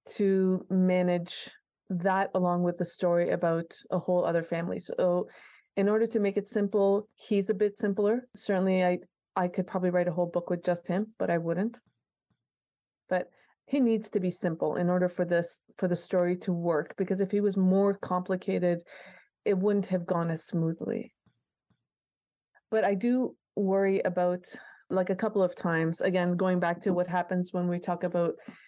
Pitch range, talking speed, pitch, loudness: 175-200 Hz, 180 wpm, 185 Hz, -29 LUFS